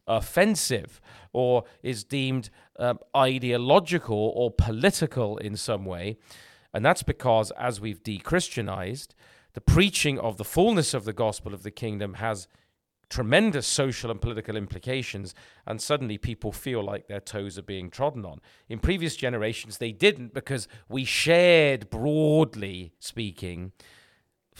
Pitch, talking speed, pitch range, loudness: 115 Hz, 135 wpm, 105-135 Hz, -26 LUFS